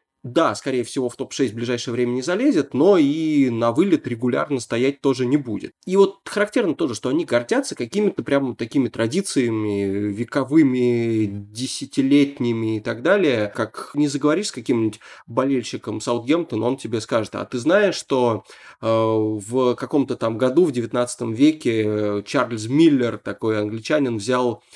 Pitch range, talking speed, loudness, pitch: 115-140 Hz, 150 wpm, -21 LUFS, 125 Hz